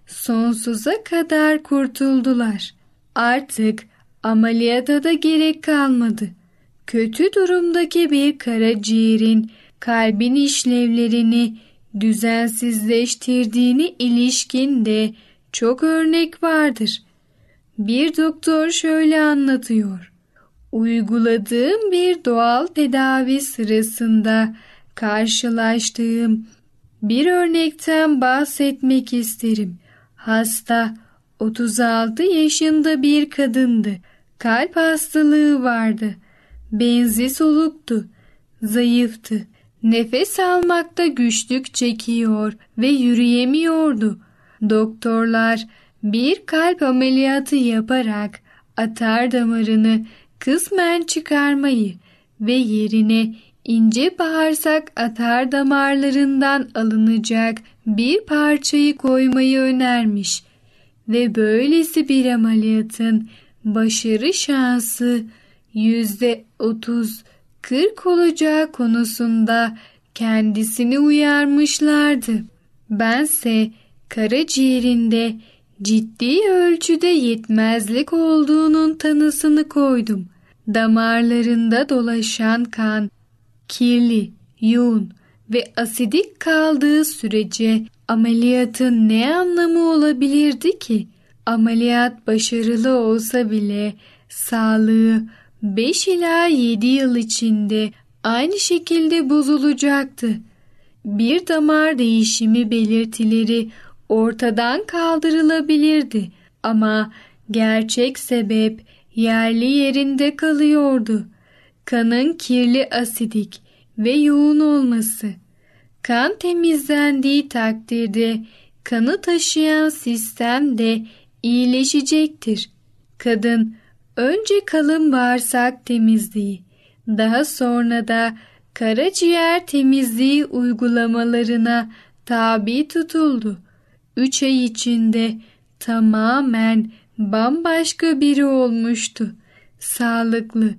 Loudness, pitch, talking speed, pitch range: -17 LUFS, 240 Hz, 70 wpm, 225-290 Hz